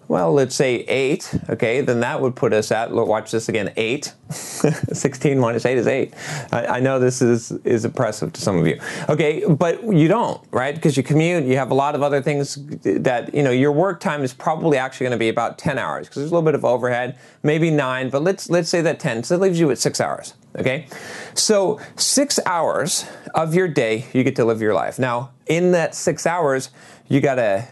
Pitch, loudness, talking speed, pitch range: 140 Hz, -20 LUFS, 225 wpm, 125-160 Hz